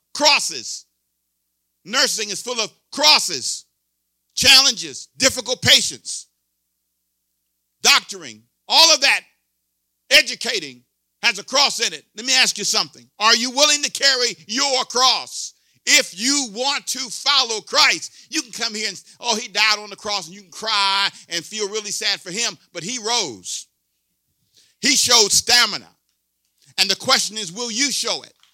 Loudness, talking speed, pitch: -17 LUFS, 150 wpm, 205 Hz